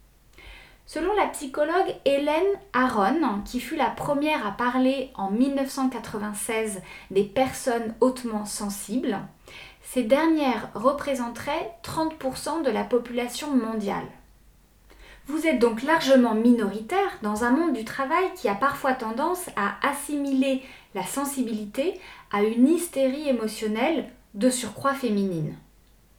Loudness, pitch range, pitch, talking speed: -25 LUFS, 225-285 Hz, 255 Hz, 115 wpm